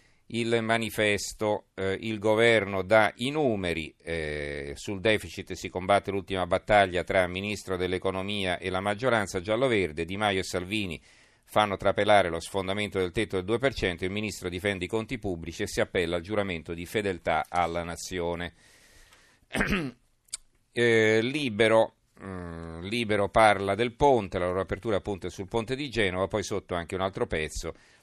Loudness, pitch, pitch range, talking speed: -27 LUFS, 95 Hz, 90-110 Hz, 155 wpm